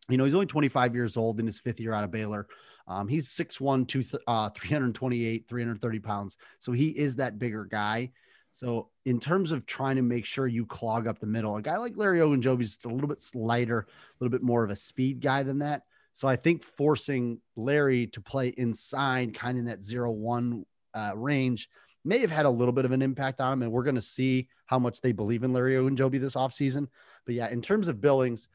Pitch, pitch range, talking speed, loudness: 125 Hz, 115-135 Hz, 230 wpm, -29 LUFS